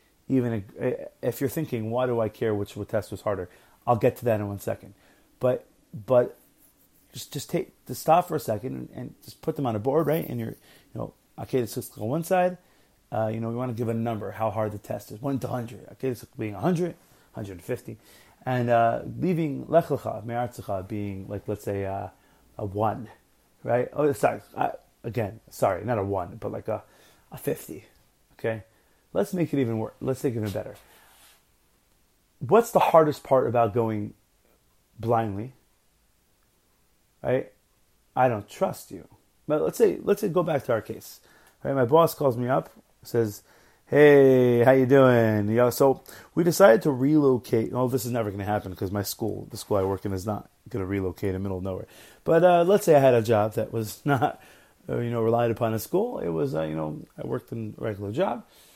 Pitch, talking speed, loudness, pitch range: 115 Hz, 205 wpm, -25 LUFS, 105-135 Hz